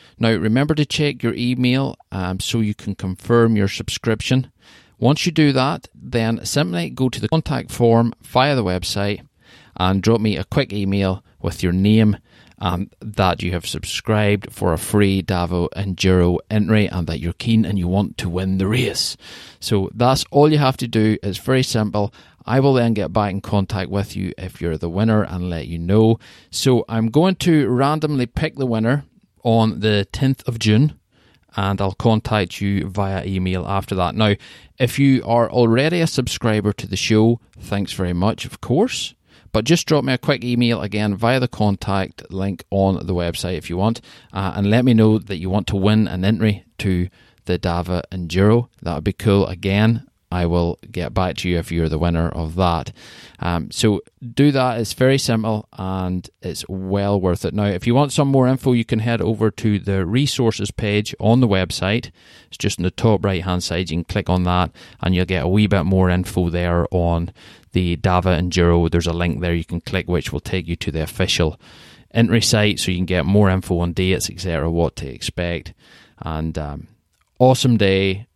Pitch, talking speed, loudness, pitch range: 100 Hz, 200 wpm, -19 LUFS, 90-115 Hz